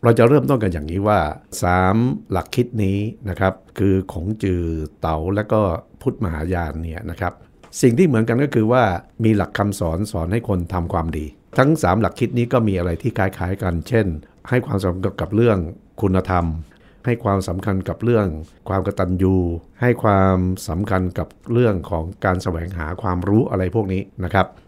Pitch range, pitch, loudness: 90-110 Hz, 95 Hz, -20 LUFS